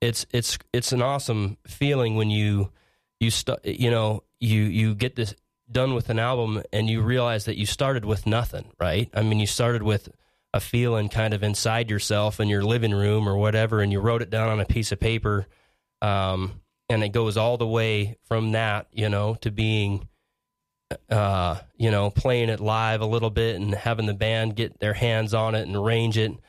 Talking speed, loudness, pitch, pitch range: 205 wpm, -24 LUFS, 110 Hz, 105-115 Hz